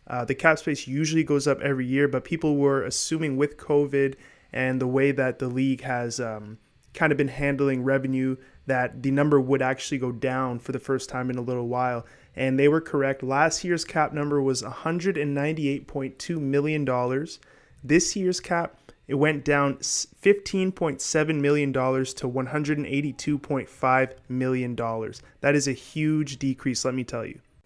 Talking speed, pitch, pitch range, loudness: 160 wpm, 140 Hz, 130-150 Hz, -25 LUFS